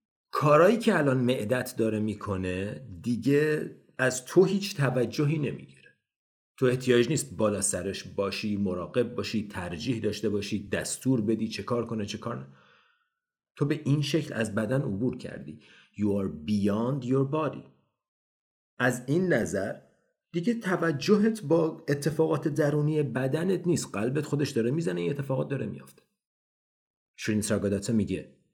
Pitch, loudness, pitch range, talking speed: 125 Hz, -28 LUFS, 105-150 Hz, 135 wpm